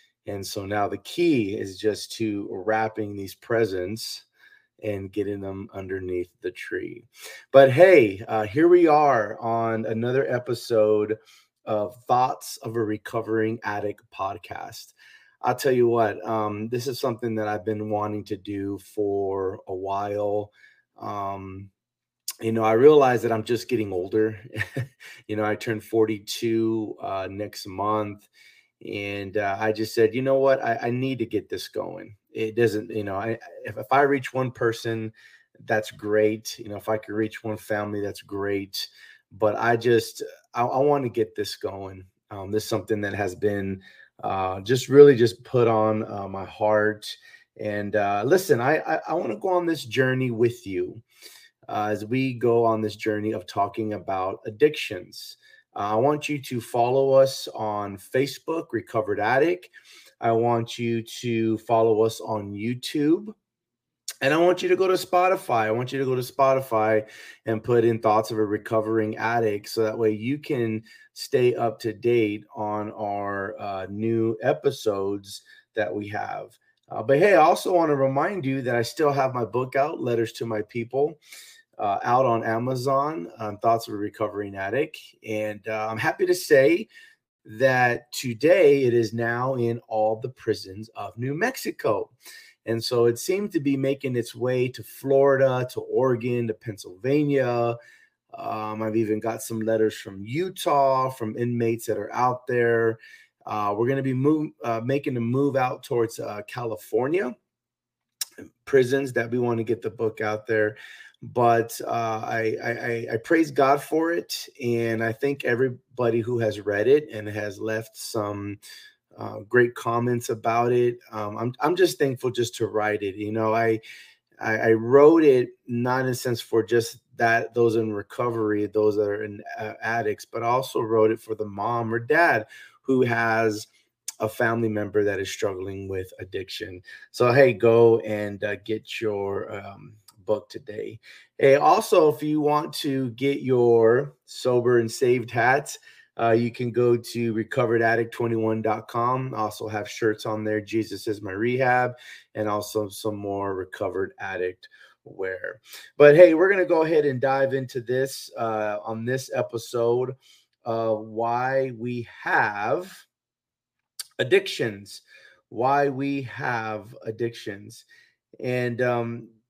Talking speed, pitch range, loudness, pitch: 165 wpm, 105-130 Hz, -24 LUFS, 115 Hz